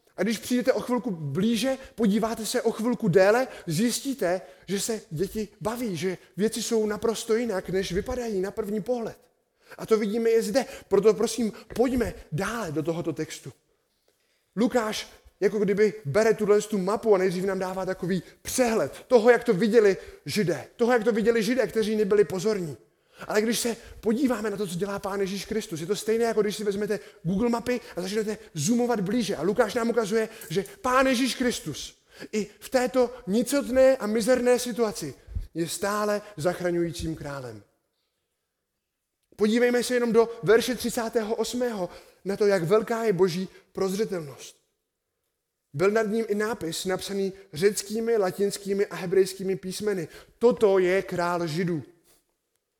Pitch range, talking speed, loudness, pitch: 190-235 Hz, 150 wpm, -26 LUFS, 215 Hz